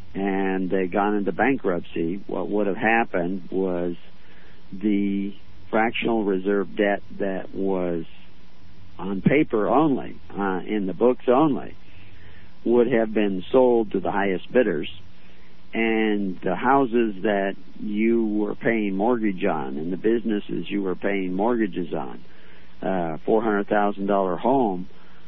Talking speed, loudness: 130 wpm, -23 LUFS